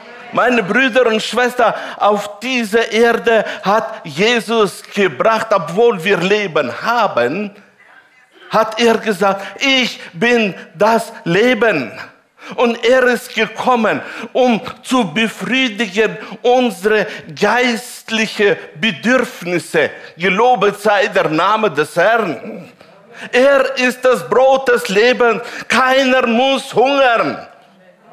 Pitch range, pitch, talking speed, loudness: 205-245 Hz, 225 Hz, 100 wpm, -14 LUFS